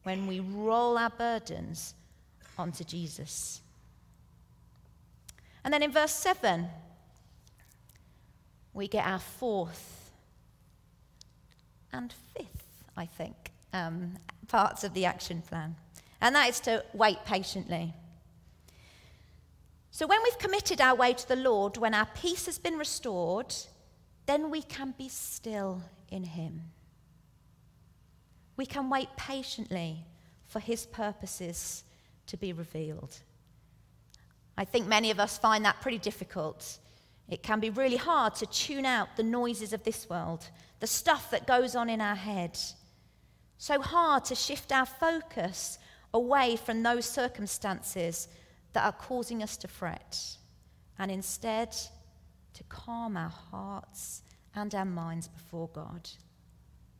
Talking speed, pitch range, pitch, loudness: 125 wpm, 170-240 Hz, 205 Hz, -32 LUFS